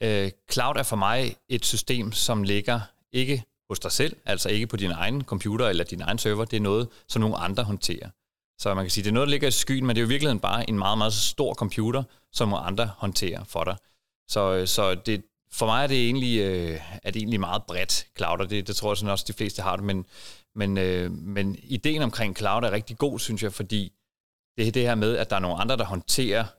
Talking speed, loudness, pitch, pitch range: 255 wpm, -26 LUFS, 105 Hz, 100-120 Hz